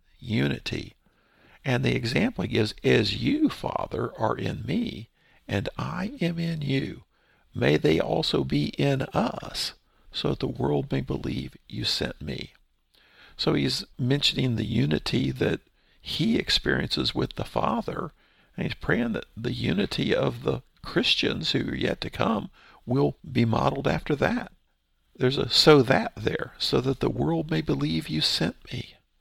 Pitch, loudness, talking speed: 135 Hz, -26 LUFS, 155 wpm